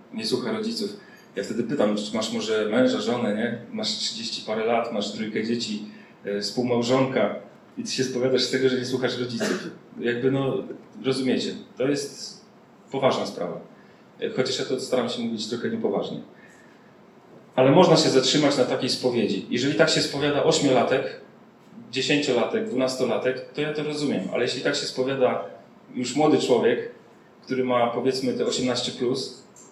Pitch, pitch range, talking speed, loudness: 130 Hz, 125-160 Hz, 155 wpm, -24 LUFS